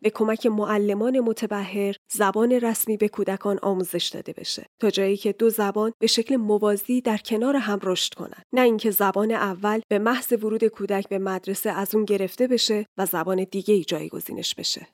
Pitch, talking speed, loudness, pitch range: 210 Hz, 175 wpm, -23 LUFS, 200-225 Hz